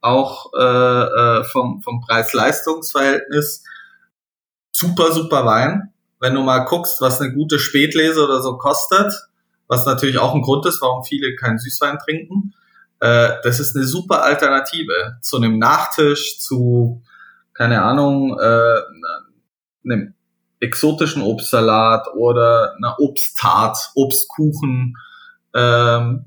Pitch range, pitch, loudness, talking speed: 120-160 Hz, 135 Hz, -16 LUFS, 120 wpm